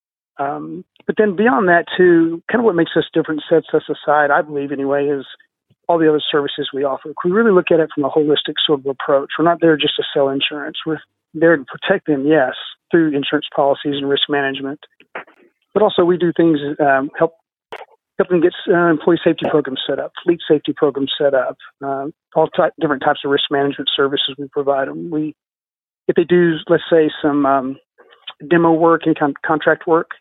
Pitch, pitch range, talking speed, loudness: 155 Hz, 140-170 Hz, 205 wpm, -16 LUFS